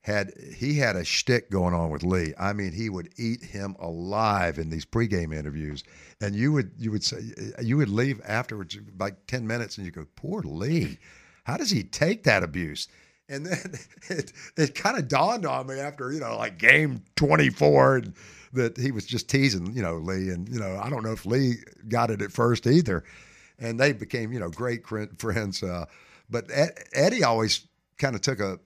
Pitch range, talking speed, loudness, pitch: 95-125 Hz, 200 wpm, -26 LUFS, 110 Hz